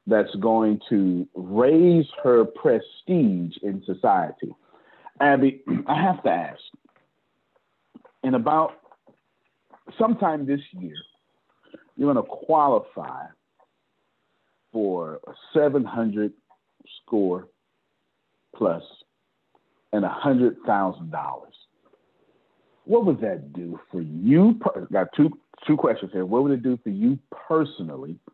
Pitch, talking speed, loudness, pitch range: 125 Hz, 110 wpm, -23 LUFS, 95-155 Hz